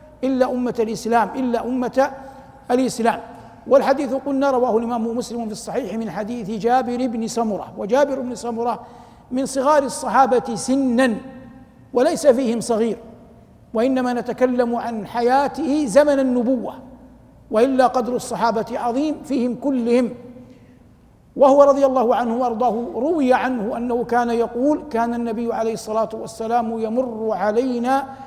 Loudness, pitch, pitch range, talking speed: -20 LUFS, 245 Hz, 230-265 Hz, 120 wpm